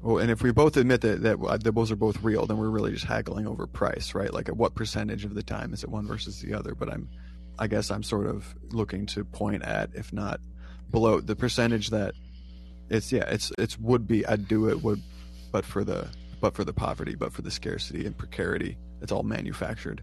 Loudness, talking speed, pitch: -28 LUFS, 230 wpm, 105 Hz